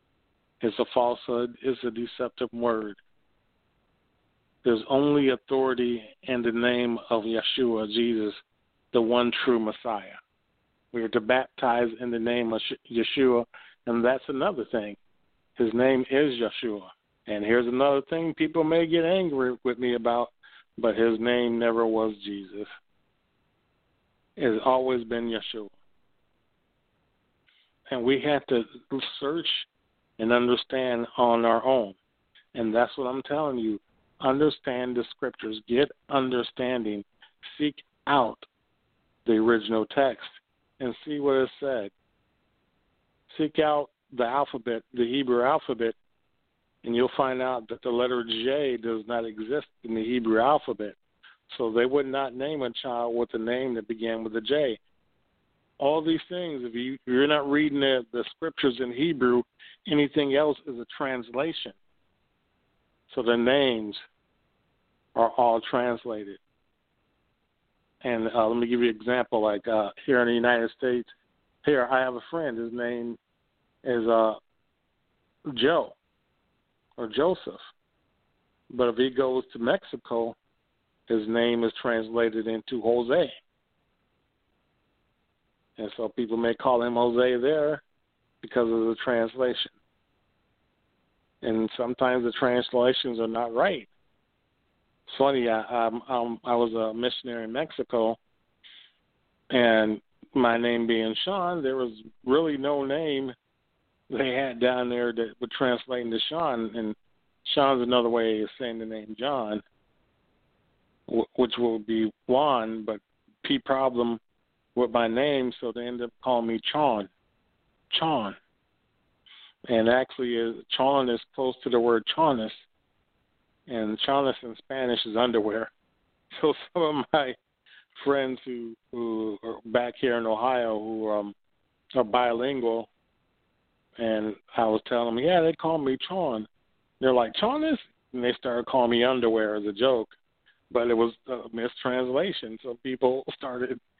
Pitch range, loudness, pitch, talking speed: 115-130 Hz, -27 LUFS, 120 Hz, 135 wpm